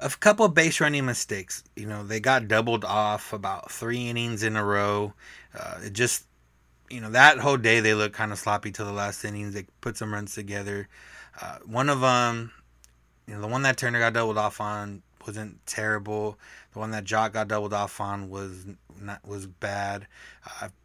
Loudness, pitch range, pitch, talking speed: -25 LUFS, 100-115 Hz, 105 Hz, 200 wpm